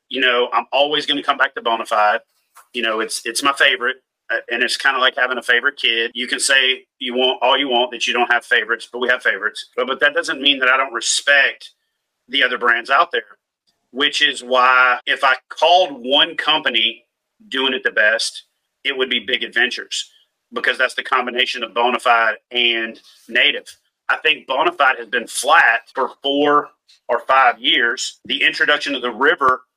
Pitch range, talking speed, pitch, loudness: 120-145 Hz, 200 wpm, 130 Hz, -16 LUFS